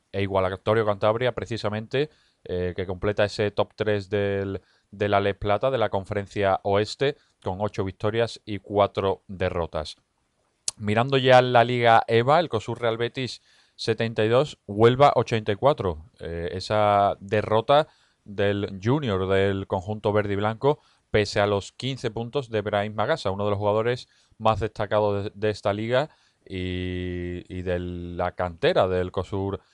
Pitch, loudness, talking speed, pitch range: 105 Hz, -24 LUFS, 150 wpm, 95-115 Hz